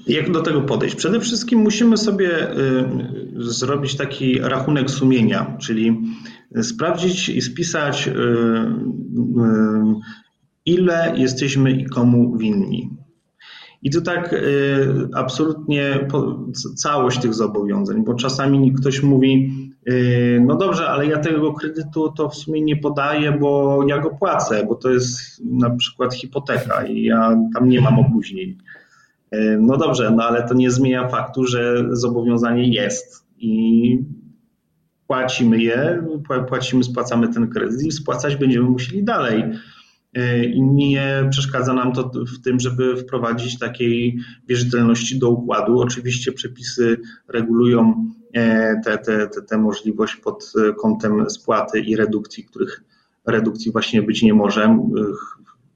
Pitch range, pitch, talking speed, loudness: 120-145 Hz, 130 Hz, 120 wpm, -18 LUFS